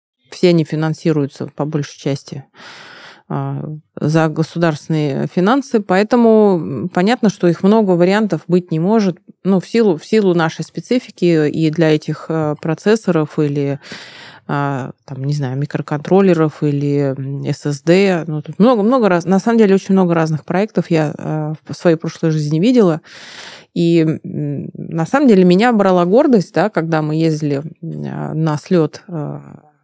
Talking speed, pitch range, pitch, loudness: 135 wpm, 150-185 Hz, 165 Hz, -15 LUFS